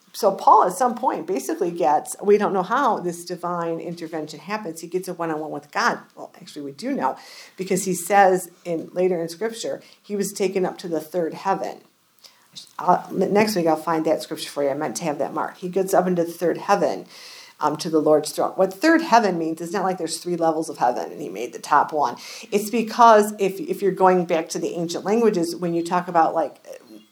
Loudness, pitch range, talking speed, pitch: -22 LUFS, 165-200 Hz, 220 wpm, 180 Hz